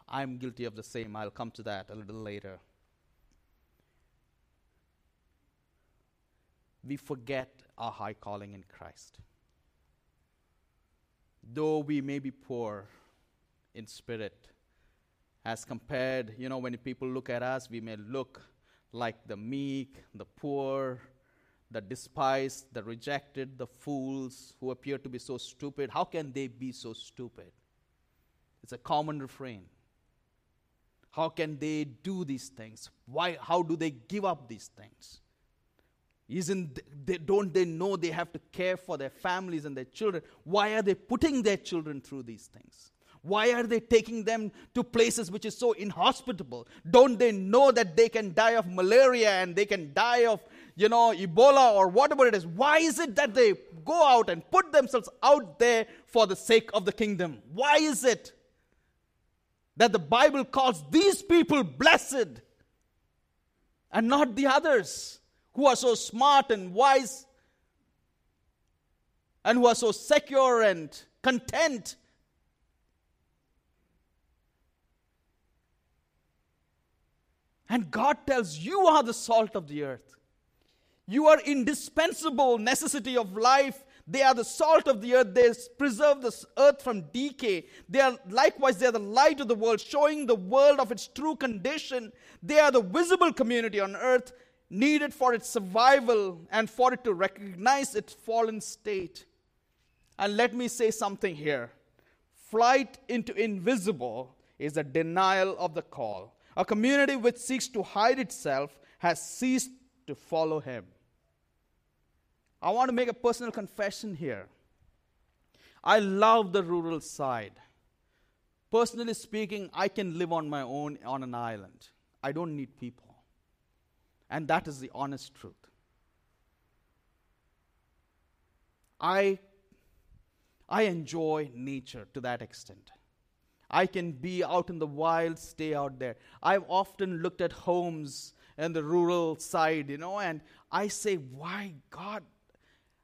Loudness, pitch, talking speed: -27 LUFS, 170 Hz, 140 wpm